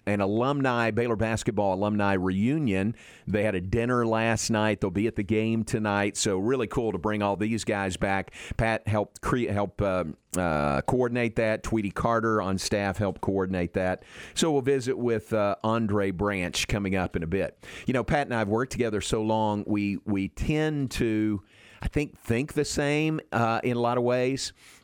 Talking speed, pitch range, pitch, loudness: 190 wpm, 100-120 Hz, 110 Hz, -27 LUFS